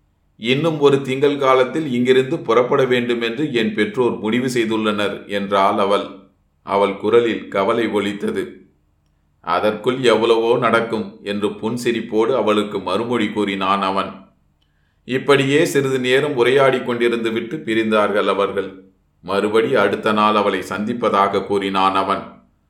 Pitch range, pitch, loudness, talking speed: 100-120 Hz, 105 Hz, -18 LUFS, 110 wpm